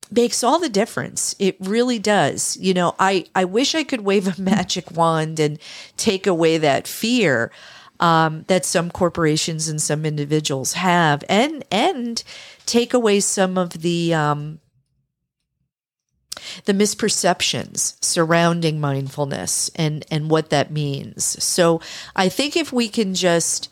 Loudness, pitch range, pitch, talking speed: -19 LUFS, 155-205 Hz, 175 Hz, 140 wpm